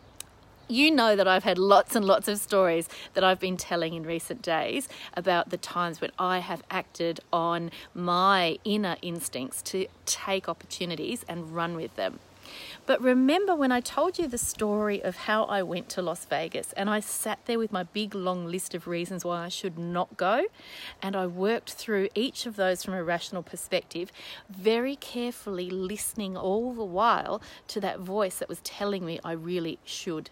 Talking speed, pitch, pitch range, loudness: 185 wpm, 185 Hz, 175-215 Hz, -28 LUFS